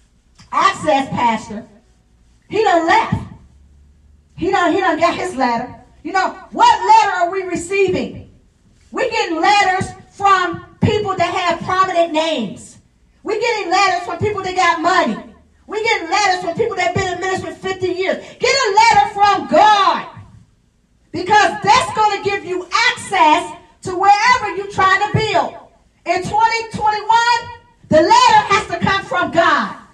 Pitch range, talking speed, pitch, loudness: 340-420 Hz, 150 wpm, 375 Hz, -15 LUFS